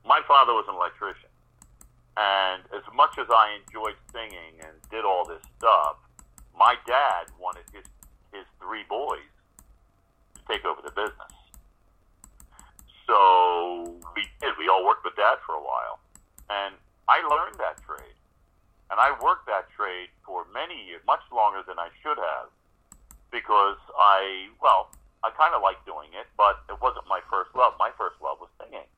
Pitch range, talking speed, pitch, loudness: 85-100 Hz, 165 wpm, 90 Hz, -24 LUFS